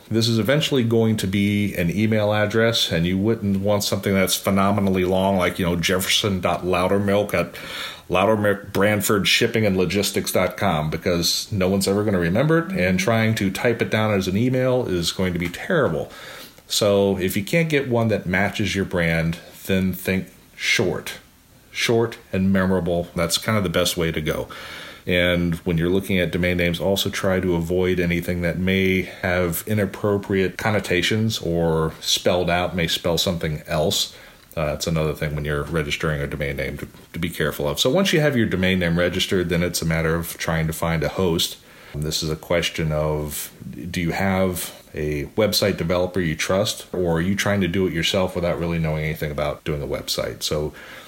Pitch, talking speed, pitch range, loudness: 90 Hz, 185 wpm, 85-100 Hz, -21 LUFS